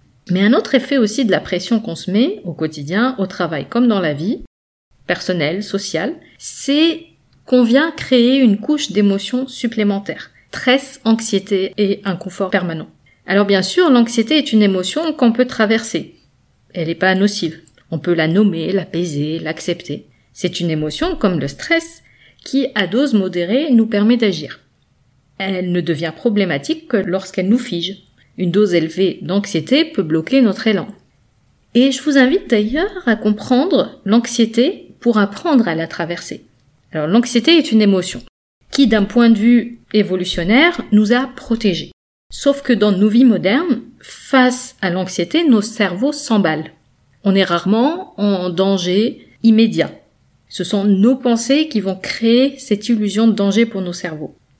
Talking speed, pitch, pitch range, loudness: 155 wpm, 210 Hz, 180-245 Hz, -16 LUFS